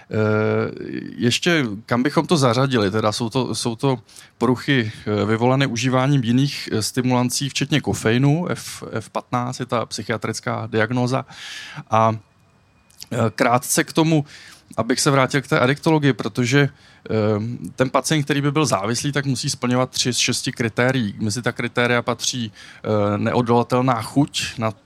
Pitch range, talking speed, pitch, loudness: 110-135 Hz, 130 wpm, 125 Hz, -20 LUFS